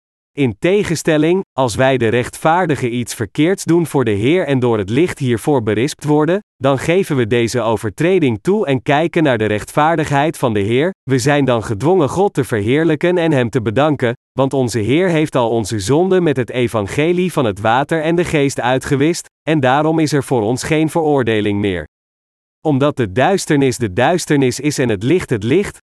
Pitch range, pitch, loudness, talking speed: 120-160 Hz, 140 Hz, -15 LUFS, 190 wpm